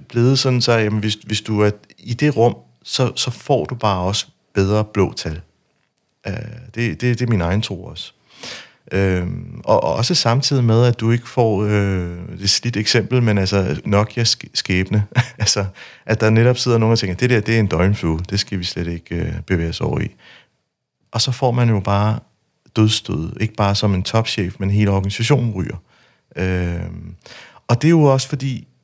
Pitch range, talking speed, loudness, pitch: 95-120 Hz, 195 wpm, -18 LUFS, 105 Hz